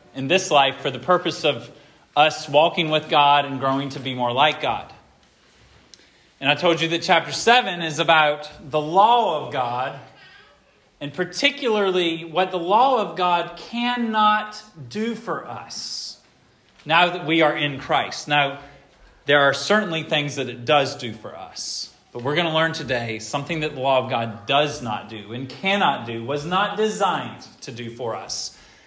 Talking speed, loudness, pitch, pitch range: 175 wpm, -21 LUFS, 150 Hz, 135-180 Hz